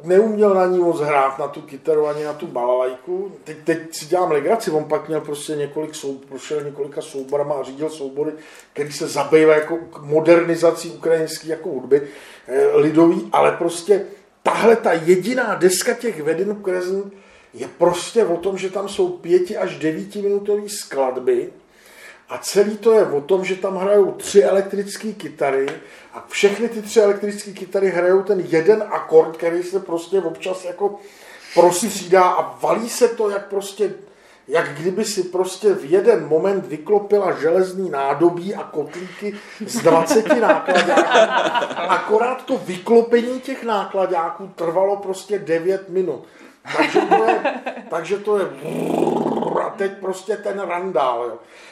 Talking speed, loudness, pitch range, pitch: 150 wpm, -19 LUFS, 160-205 Hz, 190 Hz